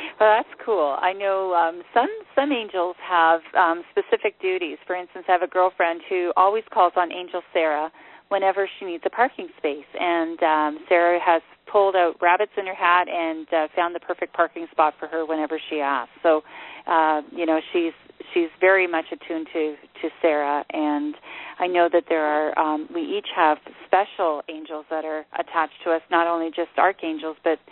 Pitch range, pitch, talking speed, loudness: 160-195 Hz, 175 Hz, 190 wpm, -22 LUFS